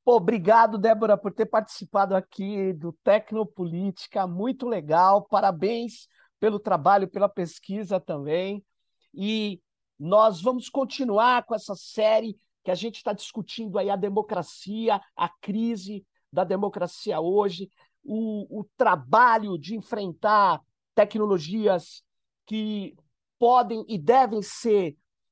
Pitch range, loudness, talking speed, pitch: 195-225 Hz, -25 LUFS, 110 wpm, 210 Hz